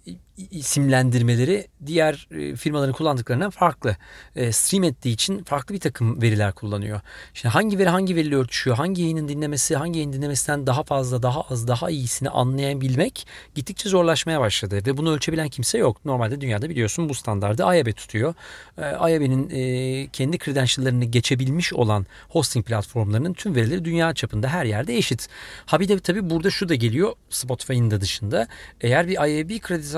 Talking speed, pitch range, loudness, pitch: 150 wpm, 120-165 Hz, -22 LUFS, 135 Hz